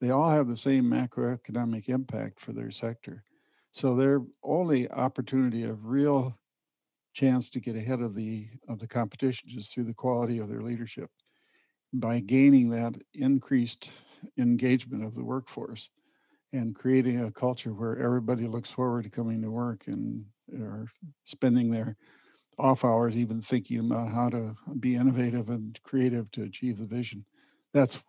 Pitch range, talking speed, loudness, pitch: 115-130 Hz, 155 wpm, -29 LUFS, 120 Hz